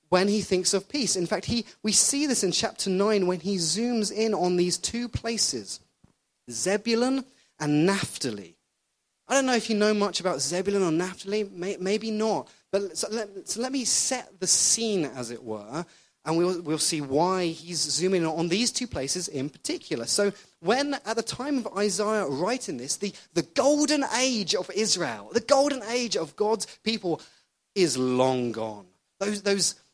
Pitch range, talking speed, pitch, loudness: 170-225 Hz, 180 wpm, 195 Hz, -26 LUFS